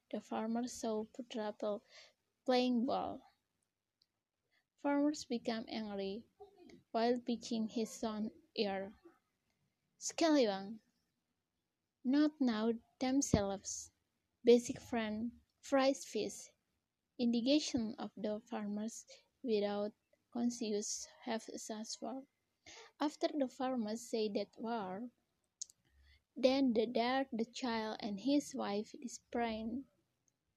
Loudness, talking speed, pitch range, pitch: -38 LUFS, 90 wpm, 215-265 Hz, 235 Hz